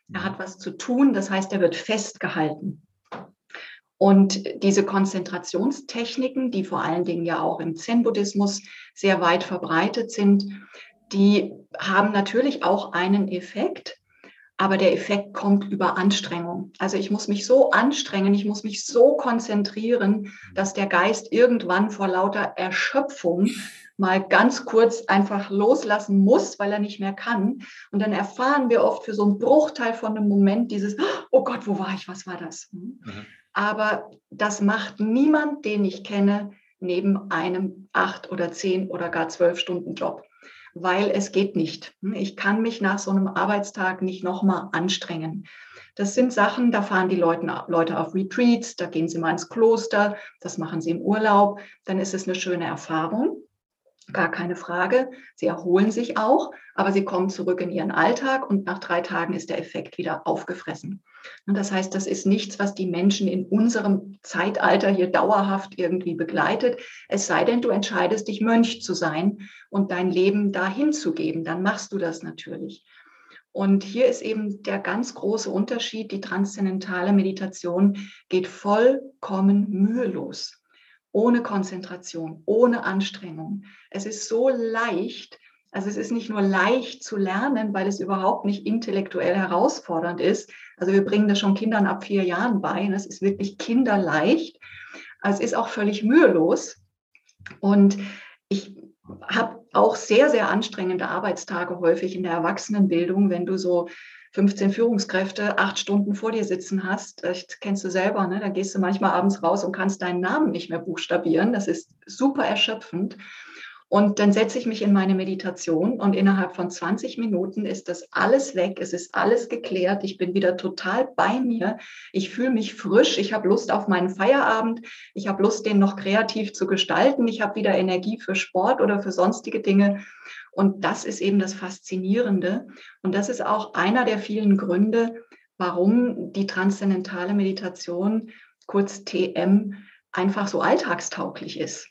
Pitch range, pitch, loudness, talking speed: 185-215 Hz, 195 Hz, -23 LUFS, 165 wpm